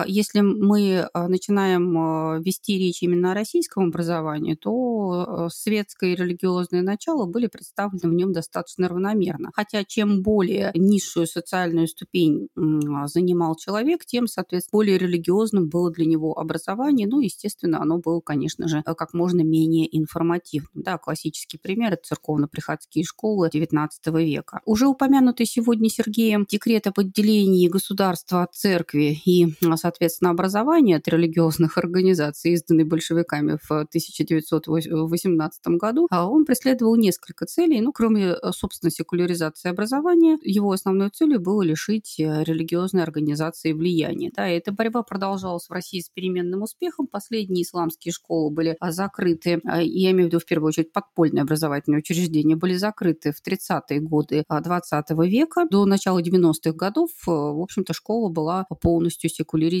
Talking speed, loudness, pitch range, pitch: 135 wpm, -22 LUFS, 165-200 Hz, 175 Hz